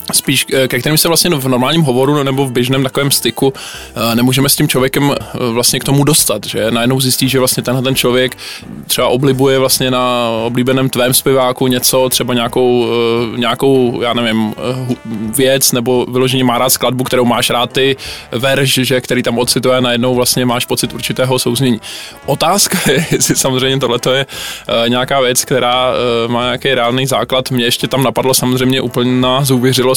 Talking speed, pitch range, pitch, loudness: 165 wpm, 125-135 Hz, 130 Hz, -12 LUFS